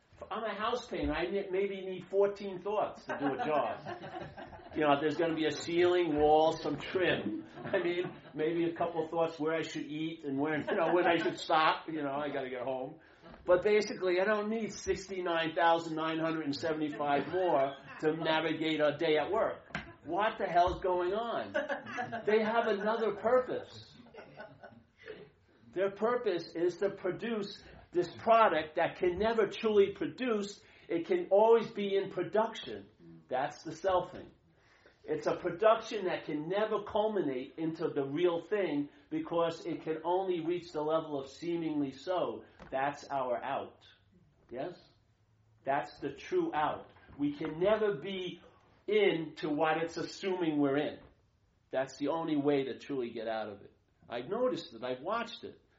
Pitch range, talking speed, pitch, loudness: 150-200 Hz, 160 wpm, 170 Hz, -33 LUFS